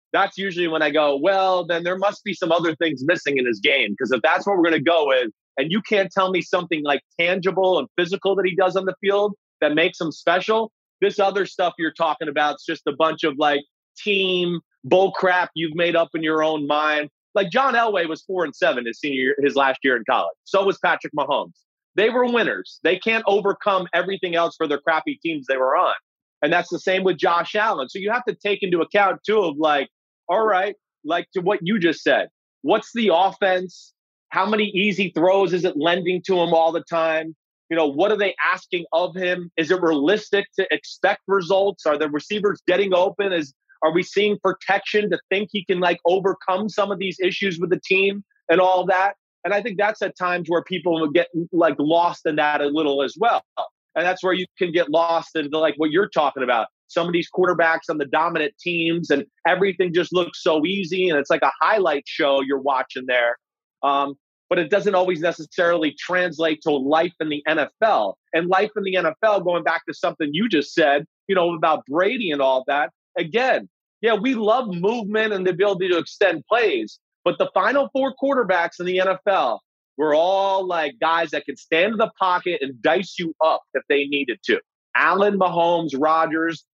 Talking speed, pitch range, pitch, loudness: 215 wpm, 160-195 Hz, 180 Hz, -21 LUFS